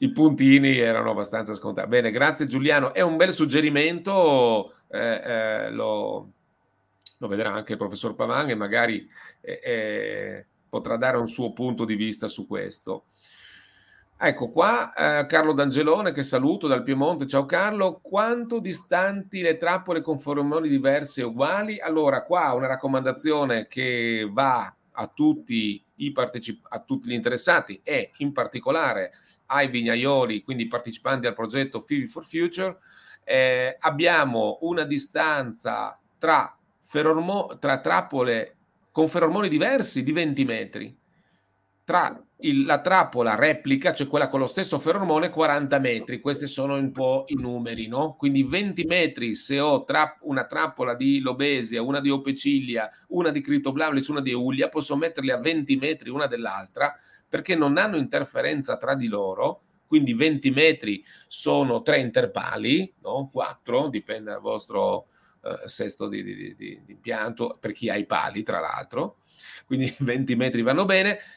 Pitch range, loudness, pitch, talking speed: 130-170 Hz, -24 LUFS, 145 Hz, 150 wpm